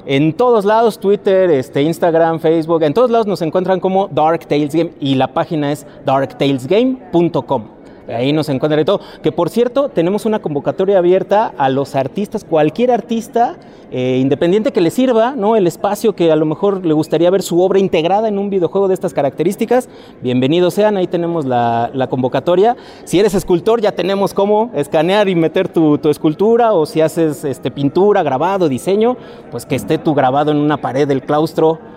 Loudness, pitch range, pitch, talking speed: -14 LUFS, 150-200 Hz, 170 Hz, 185 wpm